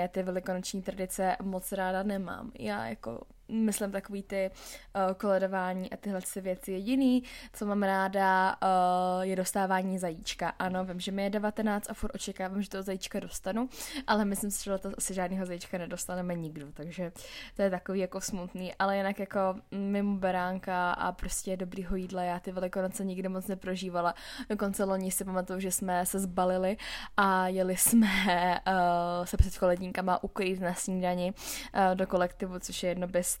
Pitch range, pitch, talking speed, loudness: 185-200 Hz, 190 Hz, 170 wpm, -31 LUFS